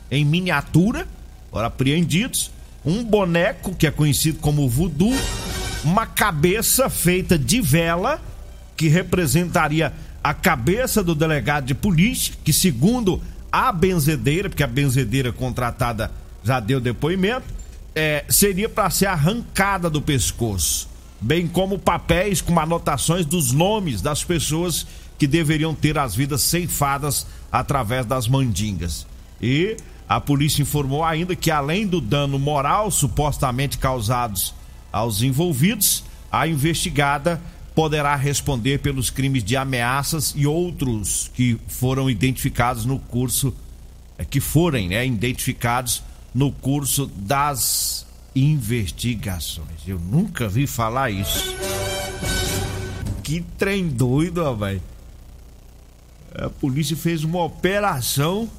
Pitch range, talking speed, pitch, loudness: 115-165 Hz, 115 wpm, 140 Hz, -21 LUFS